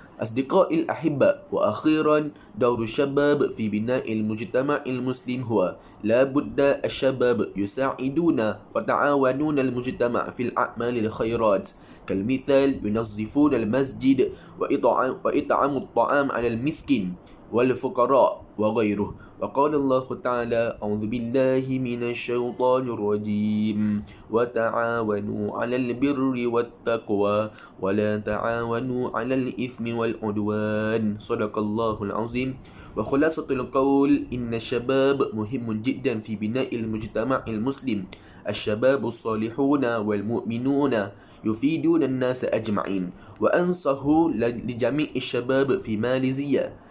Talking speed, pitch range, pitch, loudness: 90 wpm, 110-135 Hz, 120 Hz, -24 LUFS